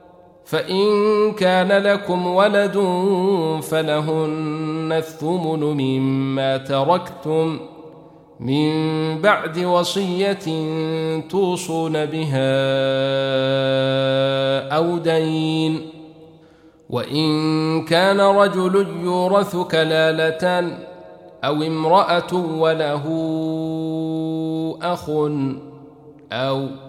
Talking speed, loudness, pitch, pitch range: 55 wpm, -19 LUFS, 160 Hz, 150-175 Hz